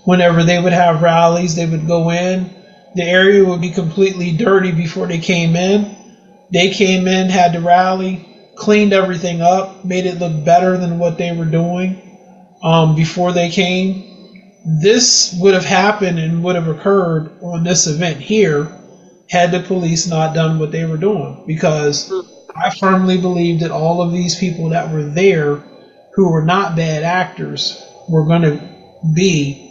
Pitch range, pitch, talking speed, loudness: 170-190 Hz, 180 Hz, 170 wpm, -14 LUFS